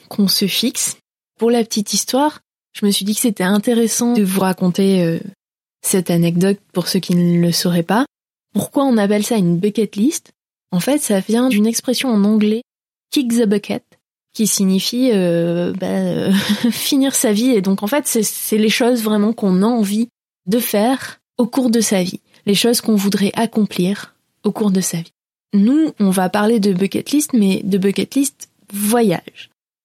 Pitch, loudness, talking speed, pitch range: 210 Hz, -16 LUFS, 190 wpm, 195-235 Hz